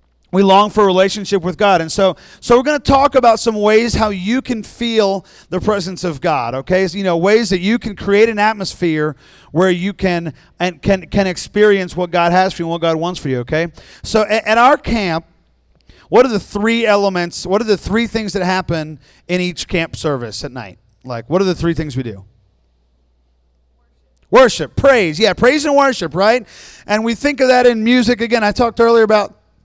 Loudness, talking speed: -14 LUFS, 215 wpm